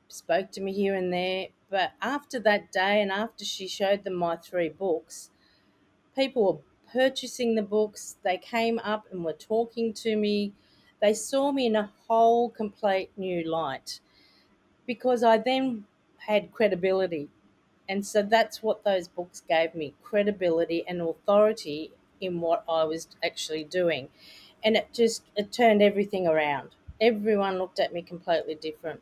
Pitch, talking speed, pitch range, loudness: 200 Hz, 155 wpm, 170-220 Hz, -27 LUFS